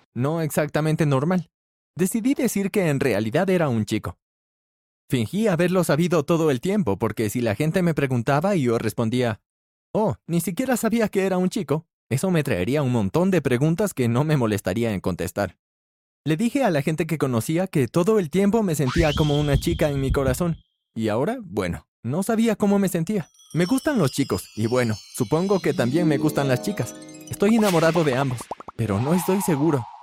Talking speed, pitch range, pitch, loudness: 190 wpm, 120-185 Hz, 155 Hz, -22 LUFS